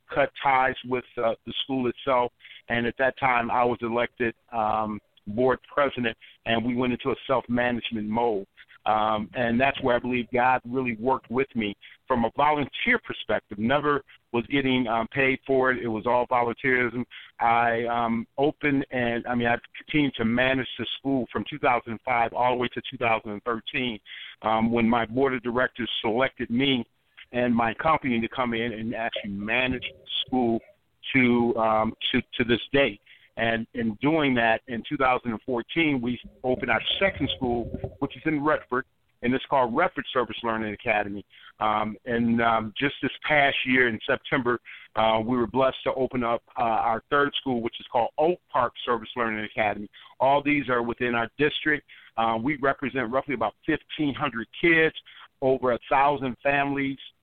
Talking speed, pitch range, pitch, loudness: 170 wpm, 115-135 Hz, 120 Hz, -25 LUFS